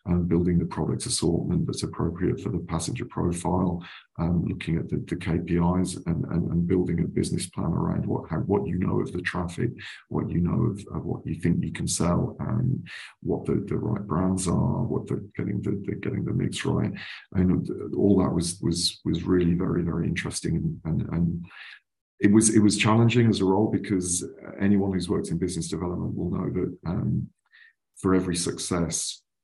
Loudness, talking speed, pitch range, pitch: -26 LUFS, 190 wpm, 85-95 Hz, 90 Hz